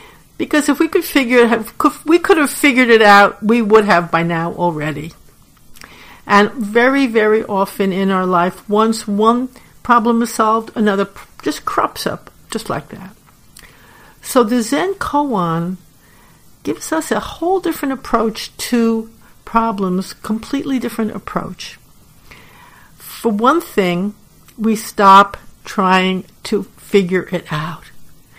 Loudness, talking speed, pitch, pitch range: -15 LUFS, 130 wpm, 220 Hz, 195-255 Hz